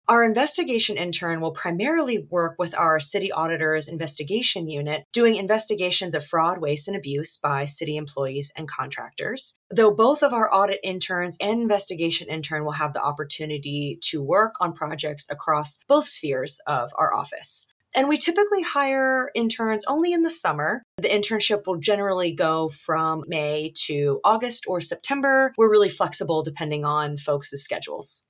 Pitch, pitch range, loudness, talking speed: 175 Hz, 155-220 Hz, -21 LUFS, 155 wpm